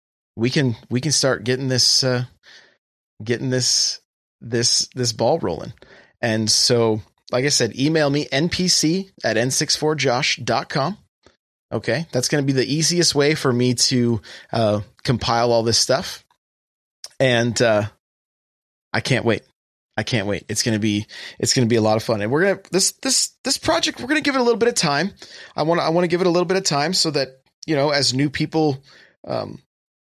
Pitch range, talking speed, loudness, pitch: 115-160 Hz, 185 wpm, -19 LUFS, 130 Hz